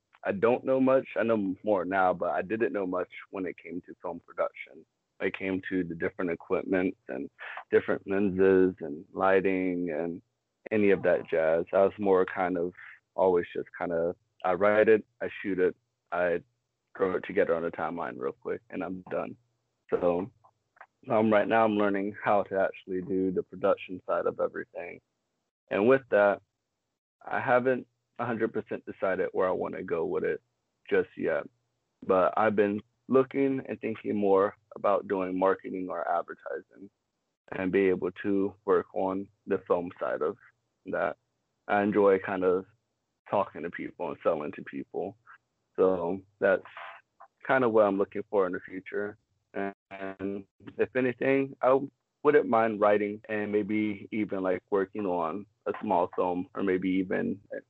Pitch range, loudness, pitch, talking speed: 95-120 Hz, -29 LUFS, 105 Hz, 165 wpm